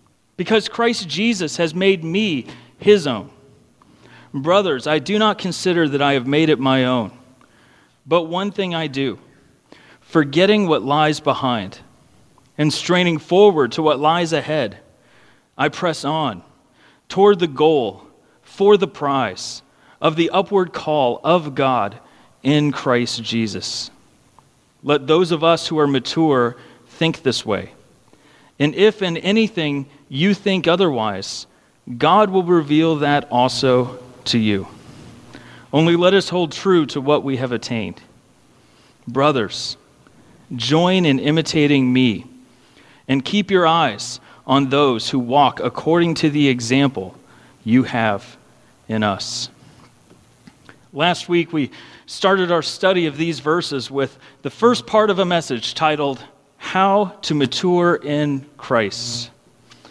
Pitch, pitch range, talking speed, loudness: 150 Hz, 130-175 Hz, 130 wpm, -18 LUFS